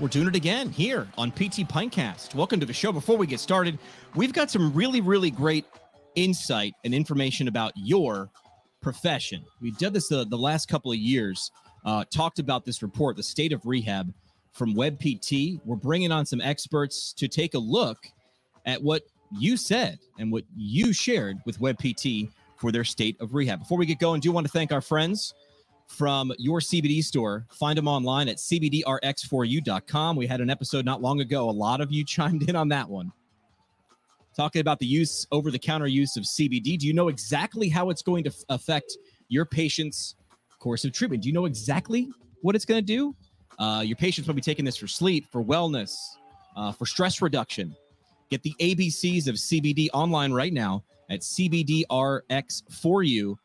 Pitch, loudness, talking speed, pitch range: 145 Hz, -26 LUFS, 185 wpm, 125-170 Hz